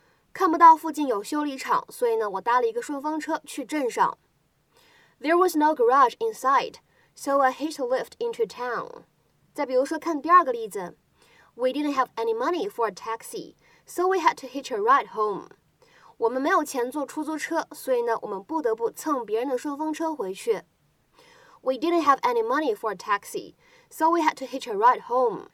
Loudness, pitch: -25 LUFS, 320 Hz